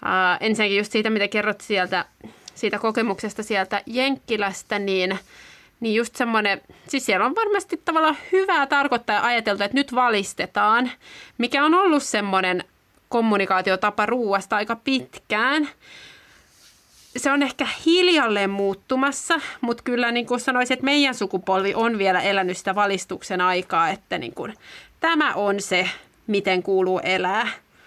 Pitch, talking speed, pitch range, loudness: 220 Hz, 135 wpm, 195-270 Hz, -22 LUFS